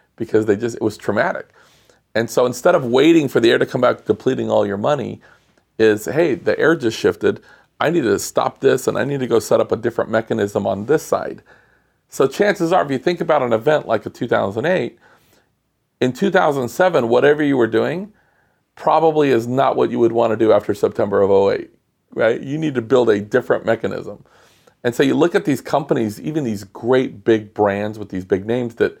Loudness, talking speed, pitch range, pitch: -18 LUFS, 210 wpm, 115-180 Hz, 130 Hz